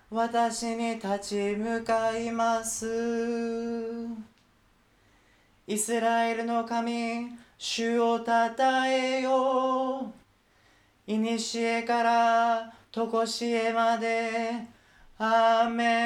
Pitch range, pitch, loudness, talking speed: 225-235 Hz, 230 Hz, -27 LUFS, 145 characters per minute